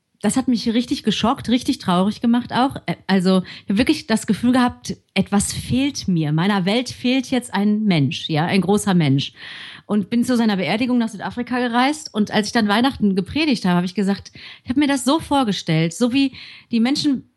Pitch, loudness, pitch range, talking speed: 220 Hz, -19 LUFS, 195-250 Hz, 195 wpm